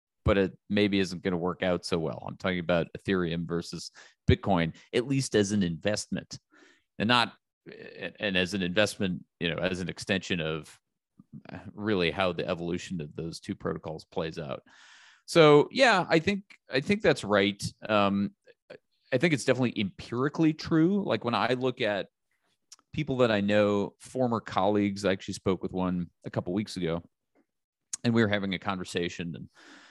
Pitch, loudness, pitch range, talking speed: 100 Hz, -28 LUFS, 90-120 Hz, 175 wpm